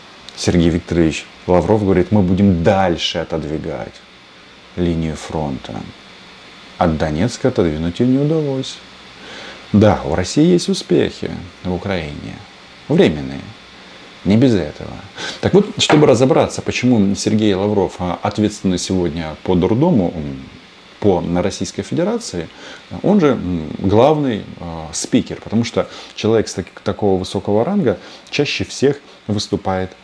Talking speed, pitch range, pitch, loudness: 120 wpm, 85-105 Hz, 95 Hz, -17 LUFS